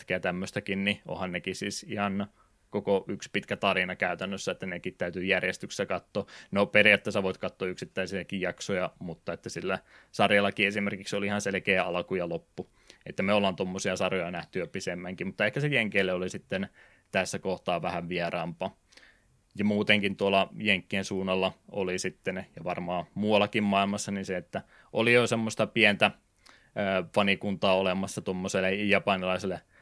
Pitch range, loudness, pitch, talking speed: 95-105 Hz, -29 LUFS, 100 Hz, 145 wpm